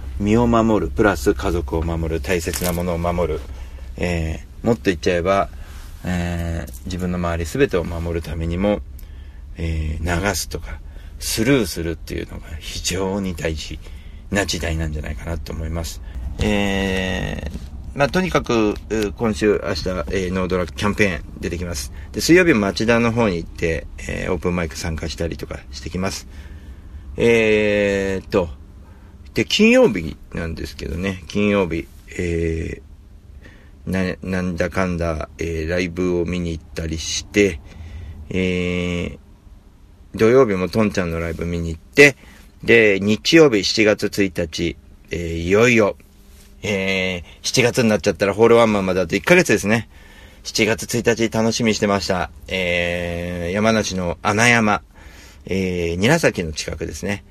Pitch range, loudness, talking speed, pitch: 80-100 Hz, -19 LUFS, 285 characters per minute, 85 Hz